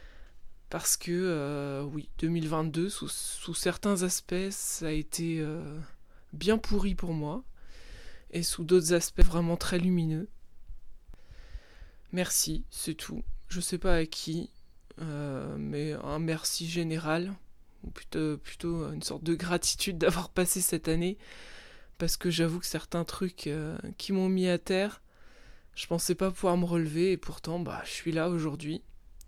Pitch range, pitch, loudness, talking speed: 155-180 Hz, 170 Hz, -31 LUFS, 150 wpm